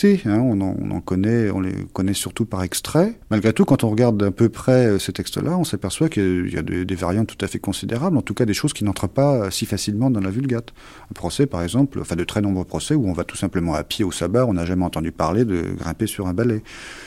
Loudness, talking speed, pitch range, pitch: -21 LUFS, 265 wpm, 95-125 Hz, 105 Hz